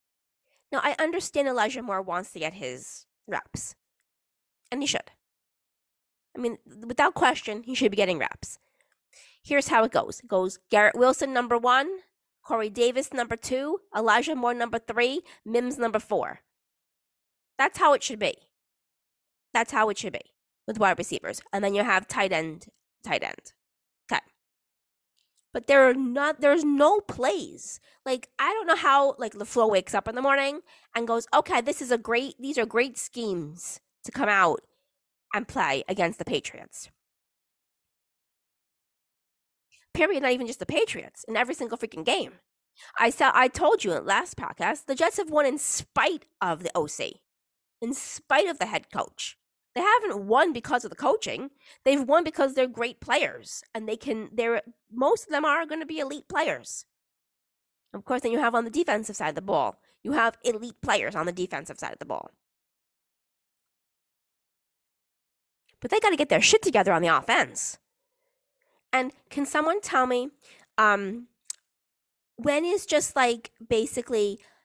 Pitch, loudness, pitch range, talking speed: 250 Hz, -26 LUFS, 225-295 Hz, 170 wpm